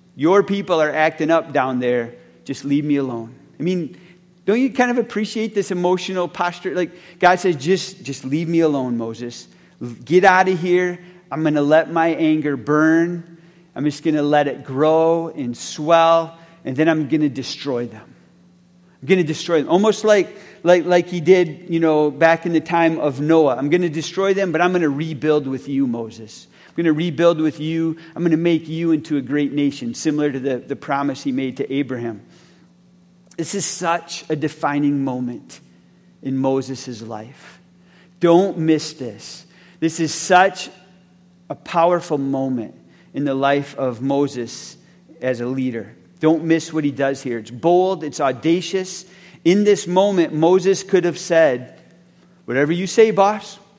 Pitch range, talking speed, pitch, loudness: 140-180 Hz, 180 wpm, 165 Hz, -19 LUFS